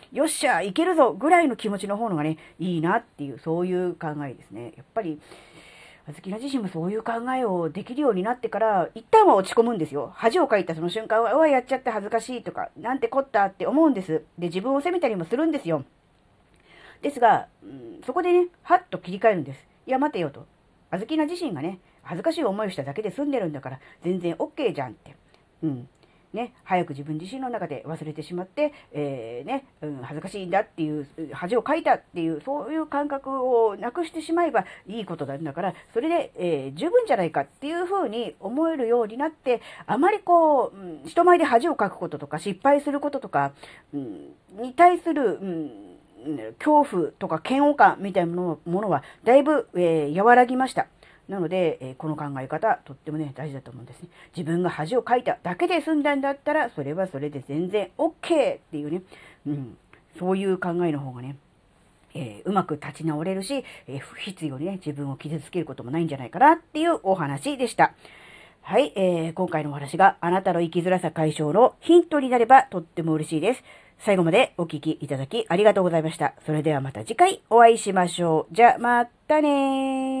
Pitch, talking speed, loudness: 190 Hz, 410 characters per minute, -24 LUFS